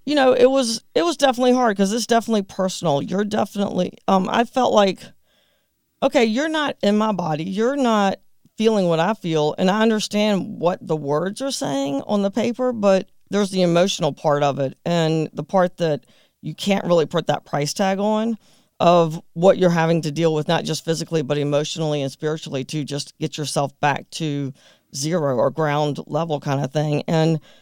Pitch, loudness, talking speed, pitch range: 175 Hz, -20 LUFS, 190 wpm, 150-215 Hz